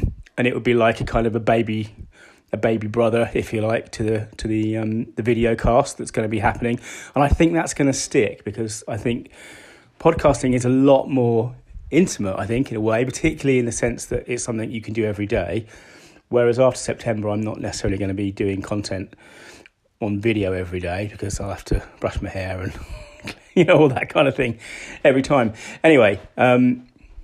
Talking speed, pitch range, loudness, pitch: 210 wpm, 105-125 Hz, -21 LUFS, 115 Hz